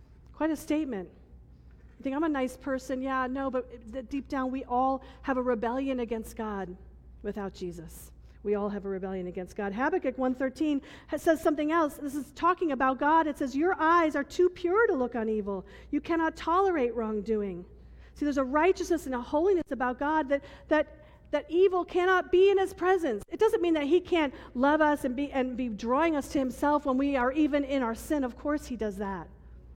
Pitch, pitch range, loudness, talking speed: 275 Hz, 240-315 Hz, -29 LUFS, 205 wpm